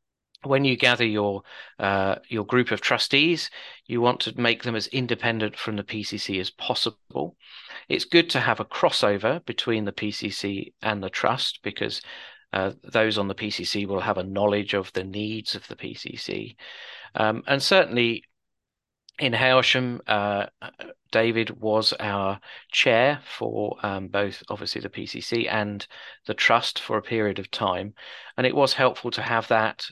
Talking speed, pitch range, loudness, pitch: 160 wpm, 100-120 Hz, -24 LUFS, 110 Hz